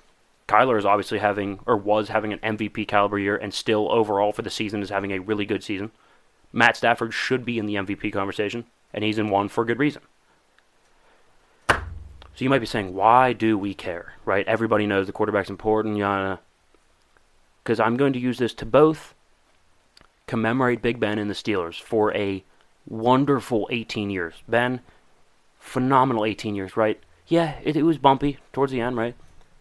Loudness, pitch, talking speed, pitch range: -23 LUFS, 110 Hz, 175 wpm, 100-120 Hz